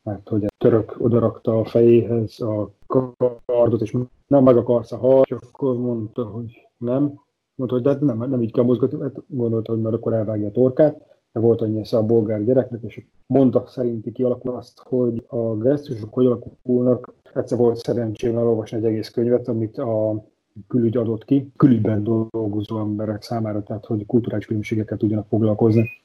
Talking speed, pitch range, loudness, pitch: 175 wpm, 110-125 Hz, -21 LUFS, 120 Hz